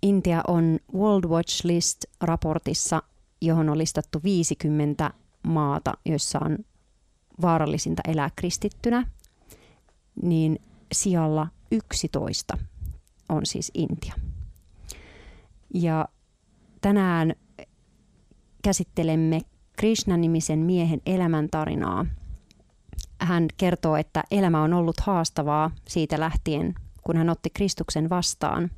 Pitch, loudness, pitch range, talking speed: 160 Hz, -25 LUFS, 150-175 Hz, 85 wpm